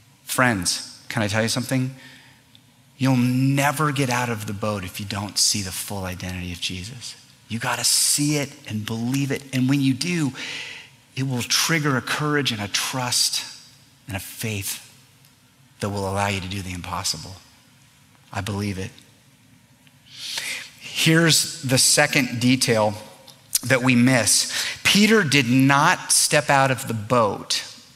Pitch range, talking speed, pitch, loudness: 110-135 Hz, 150 wpm, 125 Hz, -21 LUFS